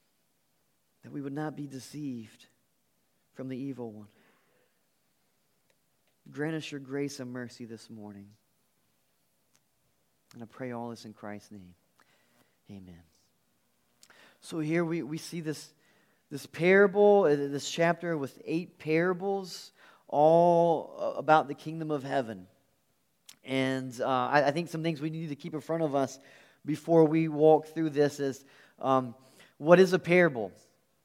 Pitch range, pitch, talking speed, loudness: 125-160 Hz, 145 Hz, 140 wpm, -28 LUFS